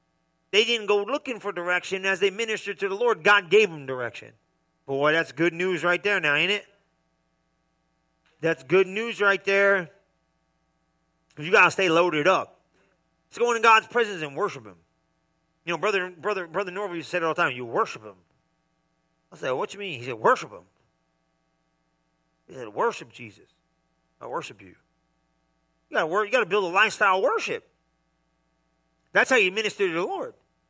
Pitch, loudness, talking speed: 165 Hz, -24 LUFS, 175 wpm